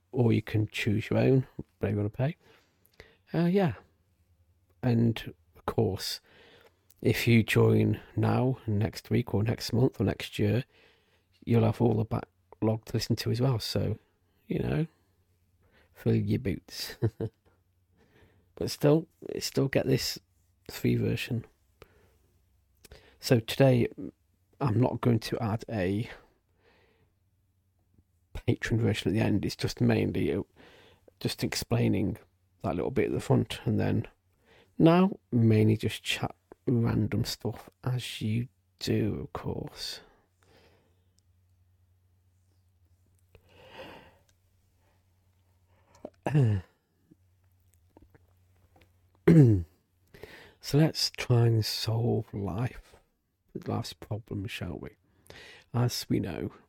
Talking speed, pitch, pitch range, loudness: 105 wpm, 100 Hz, 90-115 Hz, -29 LUFS